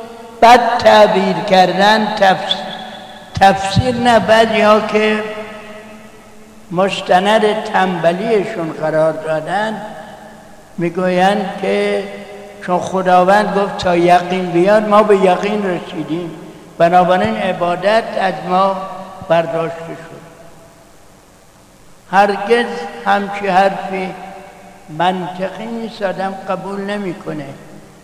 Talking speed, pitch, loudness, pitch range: 80 wpm, 190 Hz, -14 LUFS, 180-210 Hz